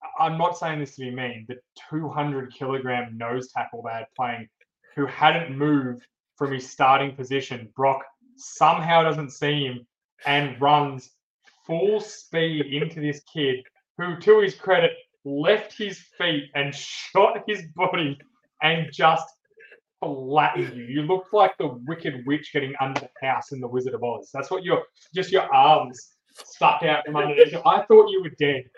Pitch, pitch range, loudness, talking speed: 150 Hz, 135-180 Hz, -23 LUFS, 165 wpm